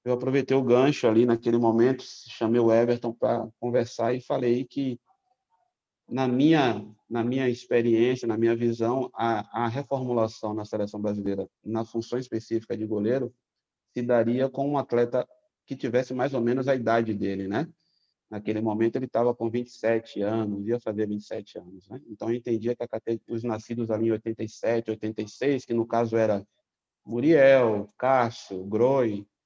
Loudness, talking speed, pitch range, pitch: -26 LUFS, 160 wpm, 110-125 Hz, 115 Hz